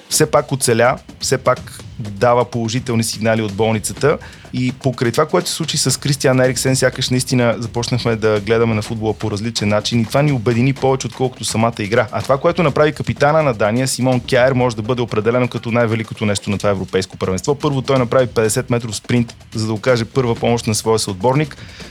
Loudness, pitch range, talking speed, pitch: -17 LUFS, 110-130 Hz, 195 wpm, 120 Hz